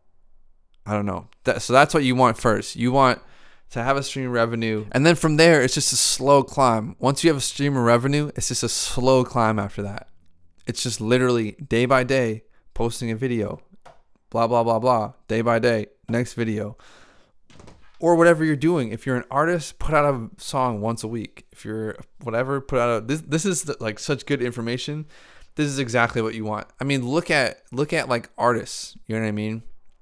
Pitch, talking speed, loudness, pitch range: 125 Hz, 210 wpm, -22 LUFS, 110-140 Hz